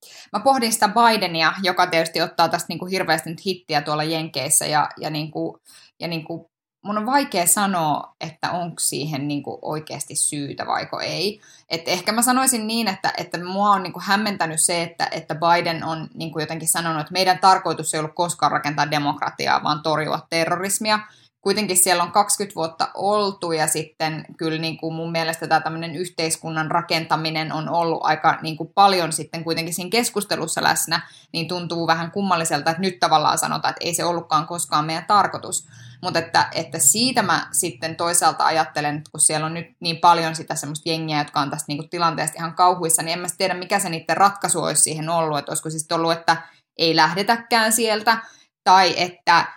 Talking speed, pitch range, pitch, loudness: 190 wpm, 160-180 Hz, 165 Hz, -20 LUFS